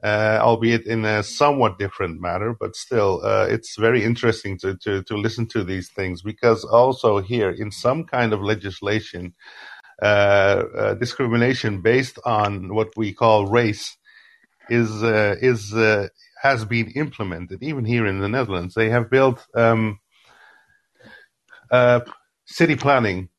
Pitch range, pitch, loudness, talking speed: 100-120 Hz, 110 Hz, -20 LUFS, 145 wpm